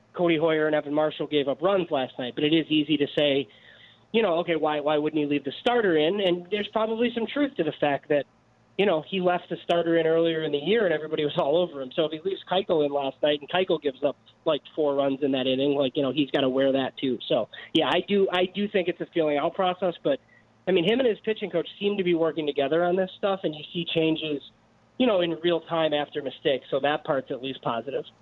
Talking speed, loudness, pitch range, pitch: 265 wpm, -25 LUFS, 145-180 Hz, 155 Hz